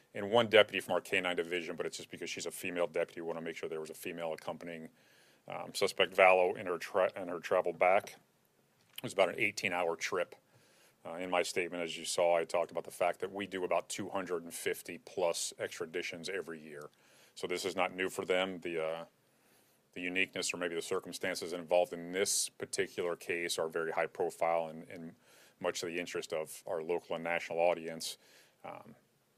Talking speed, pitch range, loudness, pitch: 205 wpm, 80-95 Hz, -35 LUFS, 85 Hz